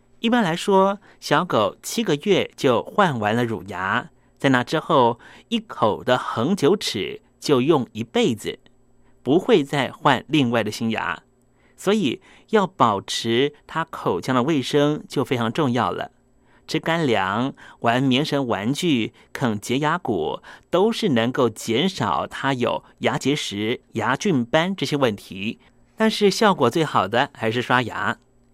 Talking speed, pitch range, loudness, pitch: 205 characters per minute, 120-165 Hz, -22 LUFS, 130 Hz